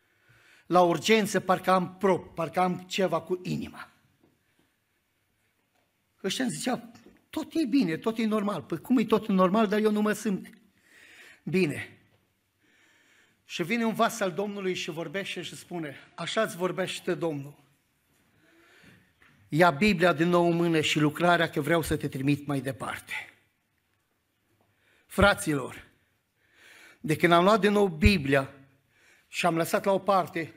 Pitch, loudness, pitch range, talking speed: 175 Hz, -27 LUFS, 145-200 Hz, 145 wpm